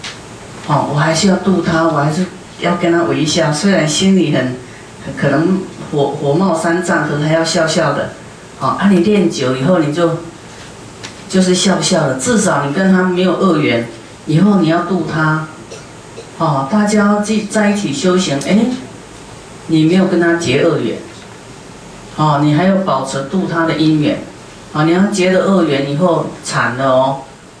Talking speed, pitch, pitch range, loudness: 235 characters per minute, 165 Hz, 145-185 Hz, -14 LUFS